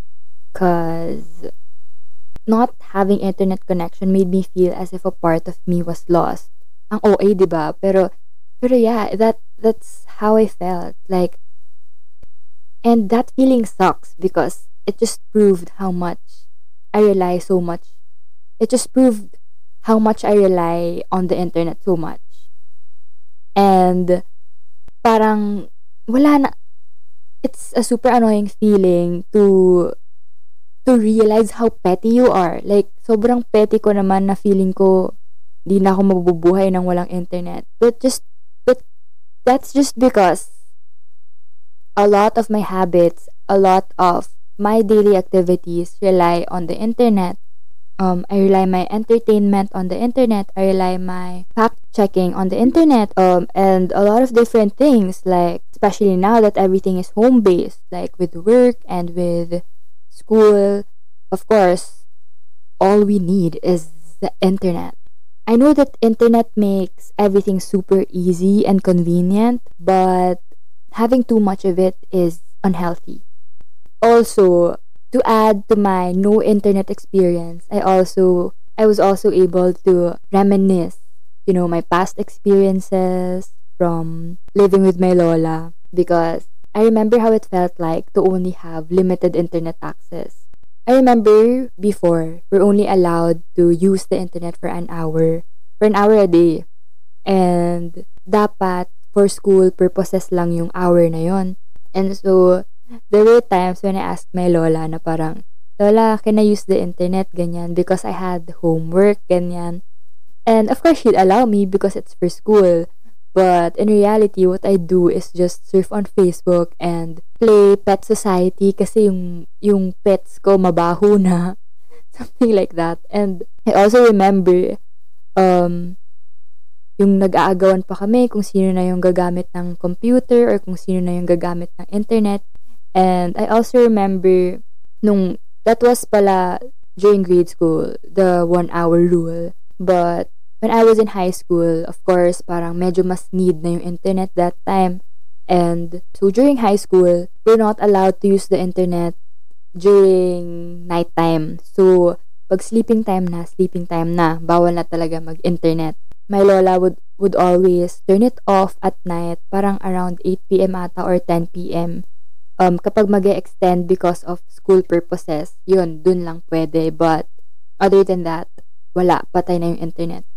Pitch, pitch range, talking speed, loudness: 185 Hz, 170-205 Hz, 145 wpm, -15 LUFS